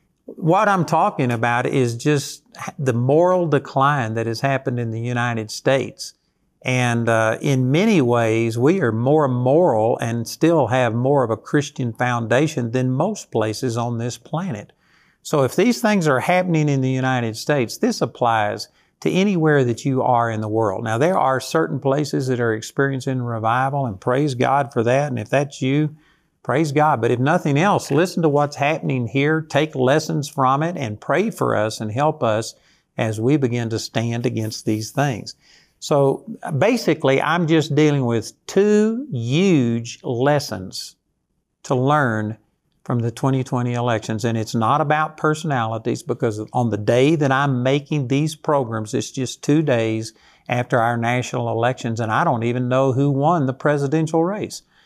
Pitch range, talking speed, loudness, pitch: 120-150 Hz, 170 wpm, -20 LUFS, 130 Hz